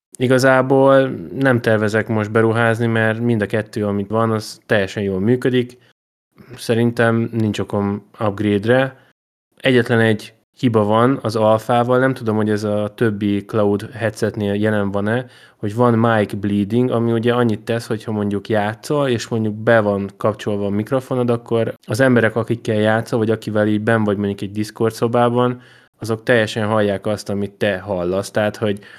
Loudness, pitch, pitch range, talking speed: -18 LUFS, 110 Hz, 105-120 Hz, 160 wpm